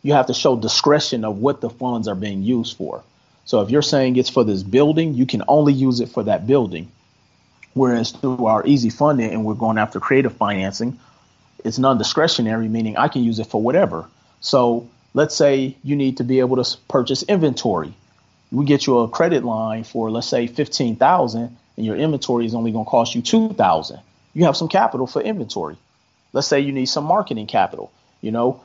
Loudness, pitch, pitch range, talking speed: -19 LUFS, 125 Hz, 110-140 Hz, 200 wpm